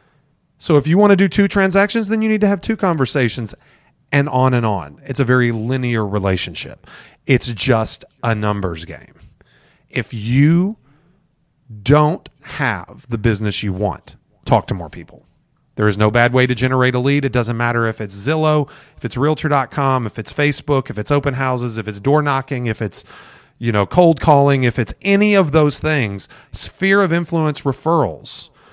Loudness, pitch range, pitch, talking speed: -17 LUFS, 115-155 Hz, 135 Hz, 180 wpm